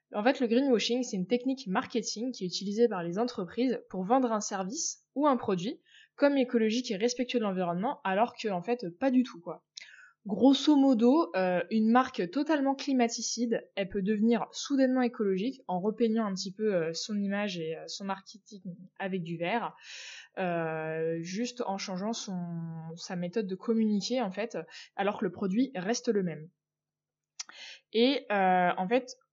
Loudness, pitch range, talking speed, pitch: -30 LUFS, 185-245 Hz, 170 wpm, 220 Hz